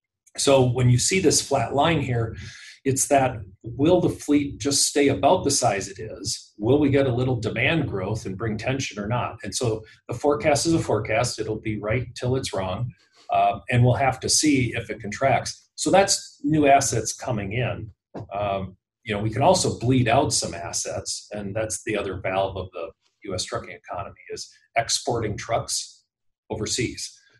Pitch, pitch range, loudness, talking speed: 125 Hz, 110-140 Hz, -23 LUFS, 185 wpm